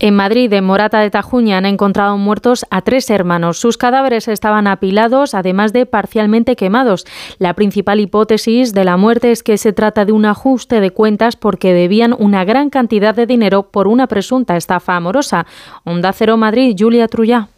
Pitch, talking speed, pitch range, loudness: 215 Hz, 175 wpm, 200-235 Hz, -12 LUFS